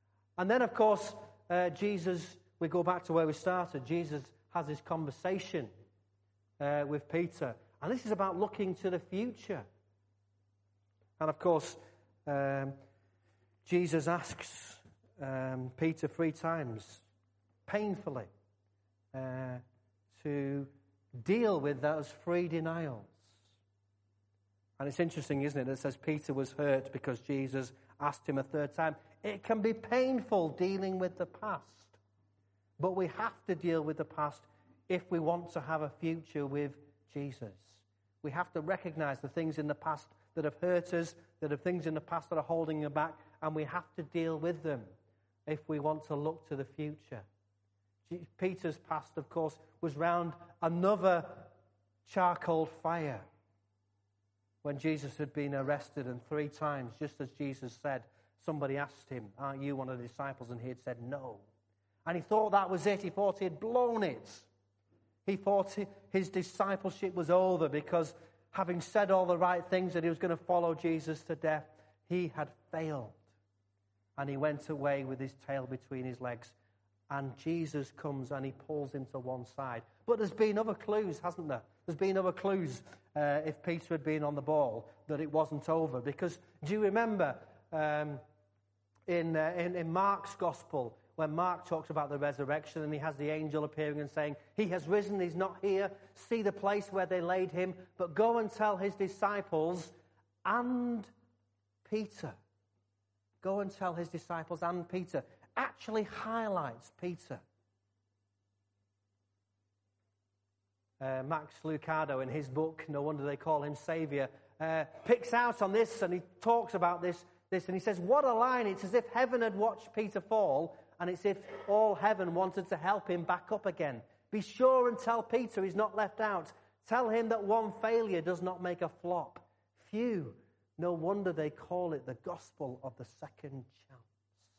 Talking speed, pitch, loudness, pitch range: 170 wpm, 155 Hz, -36 LUFS, 125-180 Hz